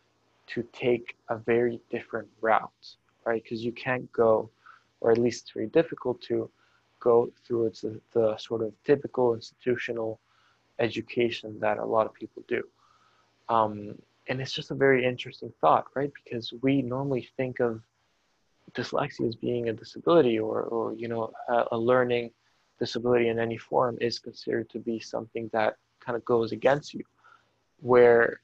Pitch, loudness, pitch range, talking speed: 120 Hz, -28 LUFS, 115-125 Hz, 160 wpm